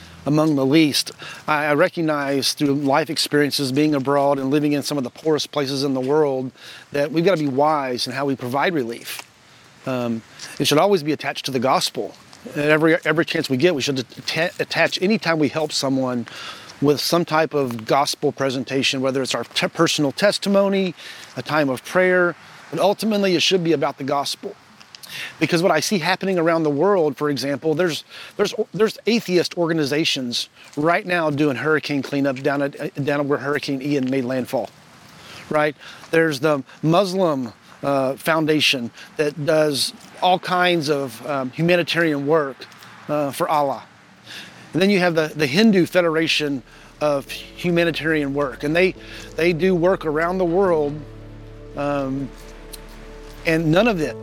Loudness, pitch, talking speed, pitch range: -20 LUFS, 150 Hz, 165 wpm, 135-165 Hz